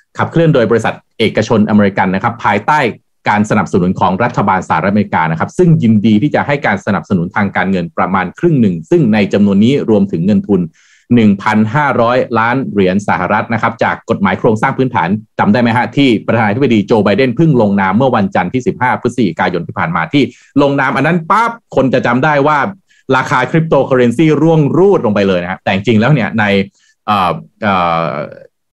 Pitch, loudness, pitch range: 125 Hz, -12 LUFS, 105-160 Hz